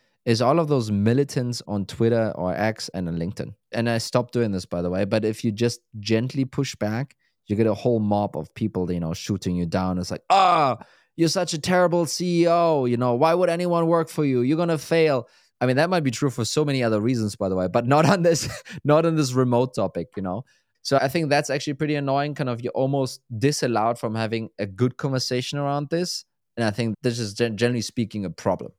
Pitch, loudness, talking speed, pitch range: 120 Hz, -23 LUFS, 230 wpm, 110-145 Hz